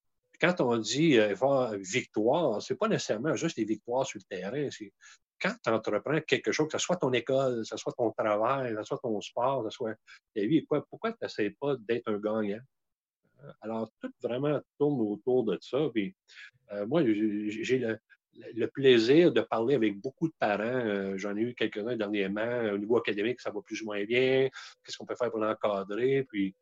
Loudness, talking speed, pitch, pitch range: -30 LUFS, 205 wpm, 115 Hz, 105-135 Hz